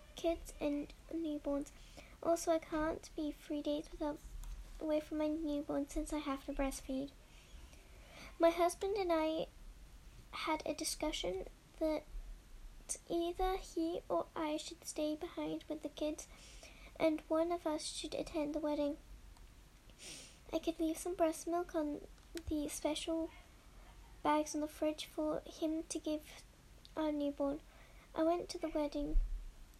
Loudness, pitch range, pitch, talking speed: -40 LUFS, 295-325 Hz, 310 Hz, 140 wpm